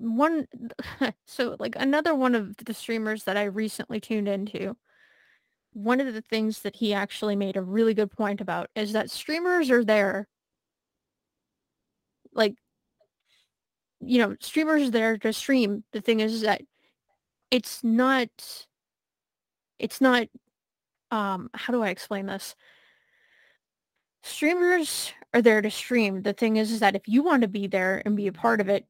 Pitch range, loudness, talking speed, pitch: 205-255 Hz, -26 LUFS, 155 wpm, 225 Hz